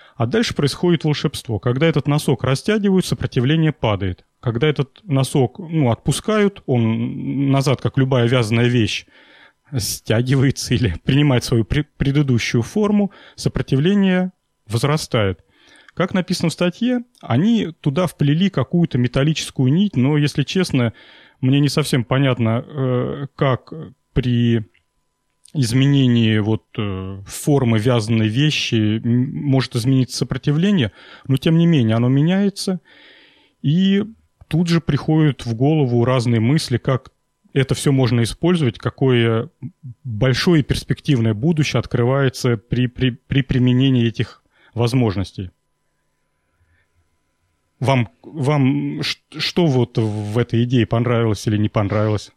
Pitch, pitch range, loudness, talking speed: 130 Hz, 115-150 Hz, -18 LUFS, 110 wpm